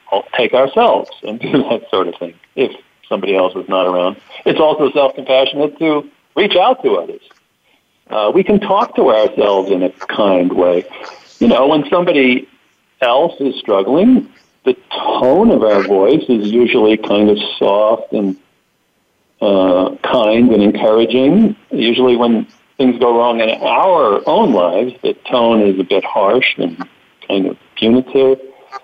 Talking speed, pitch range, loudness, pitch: 150 wpm, 110-155 Hz, -13 LUFS, 125 Hz